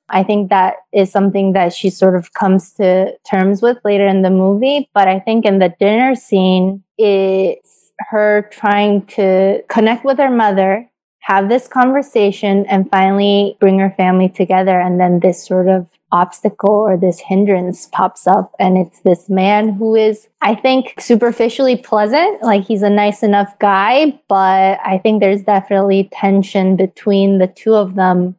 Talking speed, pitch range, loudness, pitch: 165 wpm, 190-215 Hz, -13 LUFS, 195 Hz